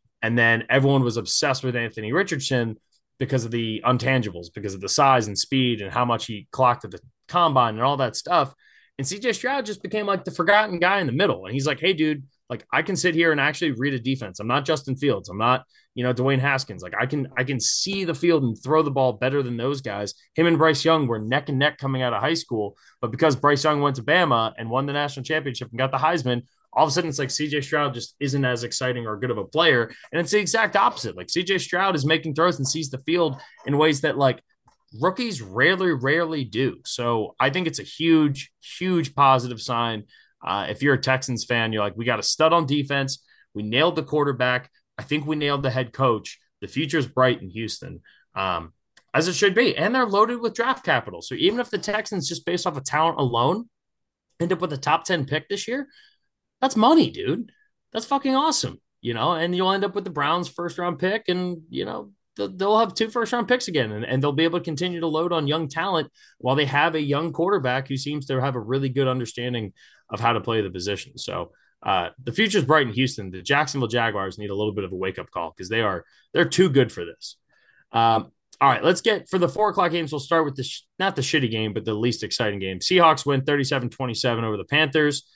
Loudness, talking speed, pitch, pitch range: -23 LUFS, 240 wpm, 140 Hz, 125-170 Hz